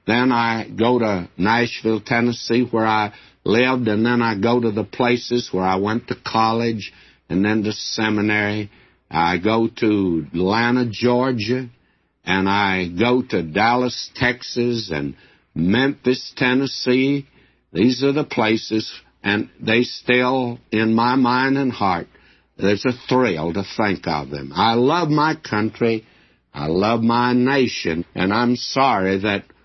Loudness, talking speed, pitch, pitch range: -19 LUFS, 140 wpm, 115 Hz, 100-125 Hz